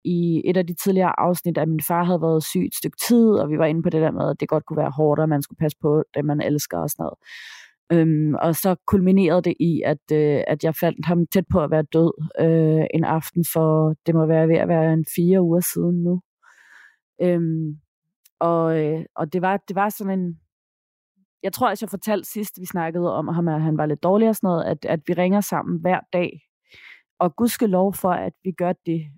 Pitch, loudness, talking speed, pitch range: 170 Hz, -21 LUFS, 240 wpm, 155-185 Hz